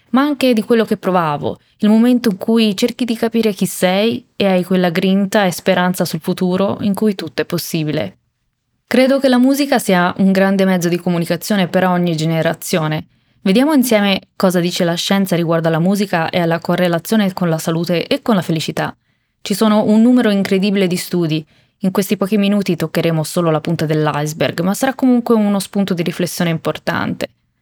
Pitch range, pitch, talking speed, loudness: 170-215 Hz, 190 Hz, 185 wpm, -15 LUFS